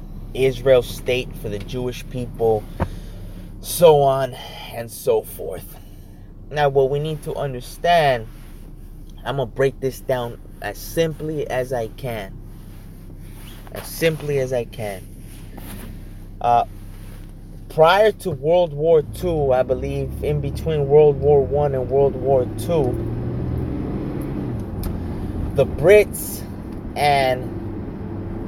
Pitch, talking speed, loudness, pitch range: 125 Hz, 110 wpm, -20 LUFS, 100-140 Hz